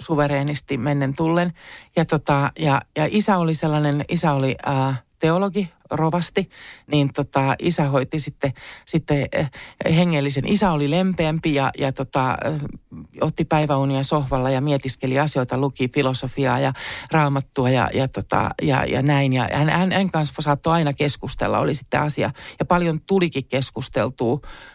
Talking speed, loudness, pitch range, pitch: 145 wpm, -21 LUFS, 135-160 Hz, 145 Hz